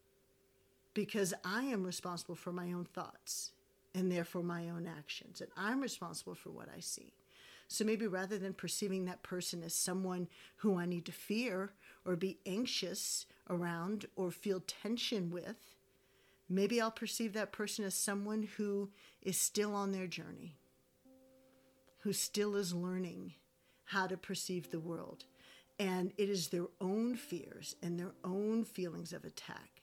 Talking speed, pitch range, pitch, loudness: 155 wpm, 175-205 Hz, 185 Hz, -40 LUFS